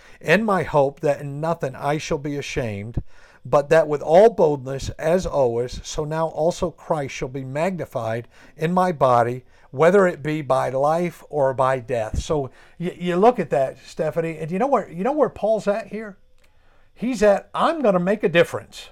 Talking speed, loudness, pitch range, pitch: 185 wpm, -21 LUFS, 135-185 Hz, 155 Hz